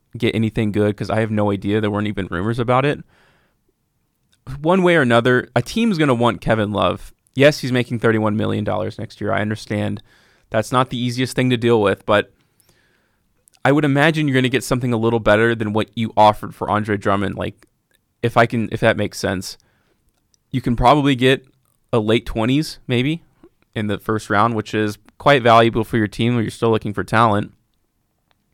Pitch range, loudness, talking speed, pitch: 105-125 Hz, -18 LUFS, 195 wpm, 115 Hz